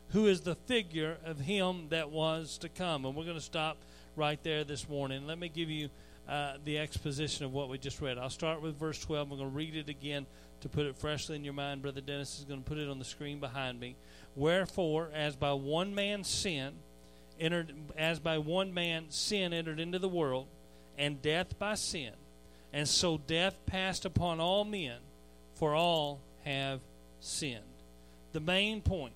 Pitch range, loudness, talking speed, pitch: 135-165 Hz, -35 LUFS, 195 wpm, 150 Hz